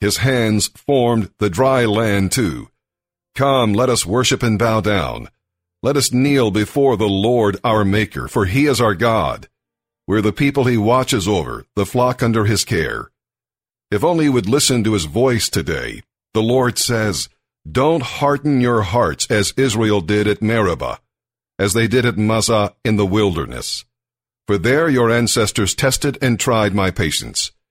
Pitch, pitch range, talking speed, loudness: 115 Hz, 105-125 Hz, 165 wpm, -17 LUFS